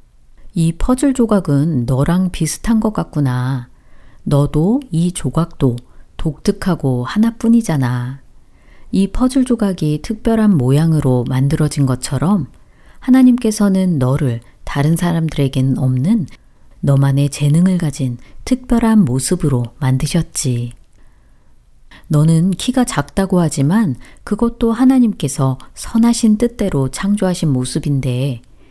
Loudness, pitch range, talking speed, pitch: -15 LUFS, 135-210 Hz, 250 characters per minute, 160 Hz